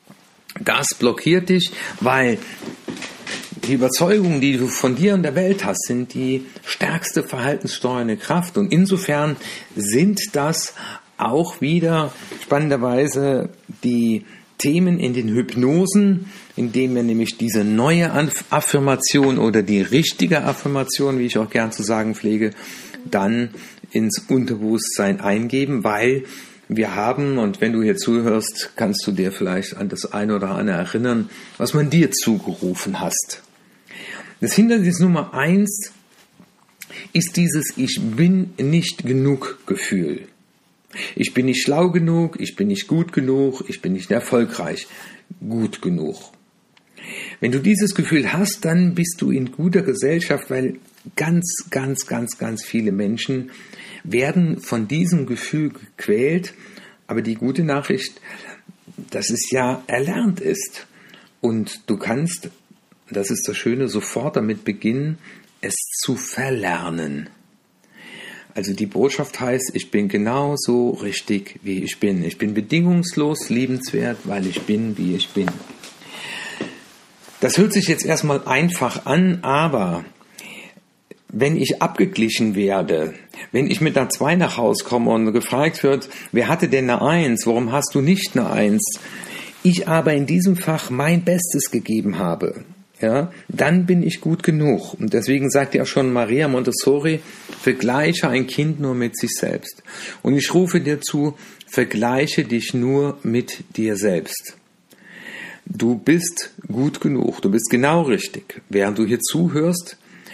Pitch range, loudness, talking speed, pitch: 120-175 Hz, -20 LUFS, 140 wpm, 140 Hz